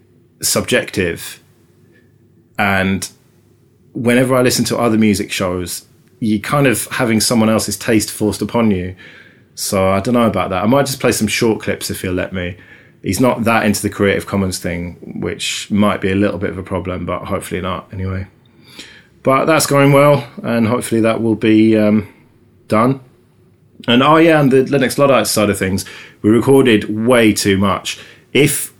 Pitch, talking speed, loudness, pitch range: 110 Hz, 175 wpm, -15 LUFS, 95-125 Hz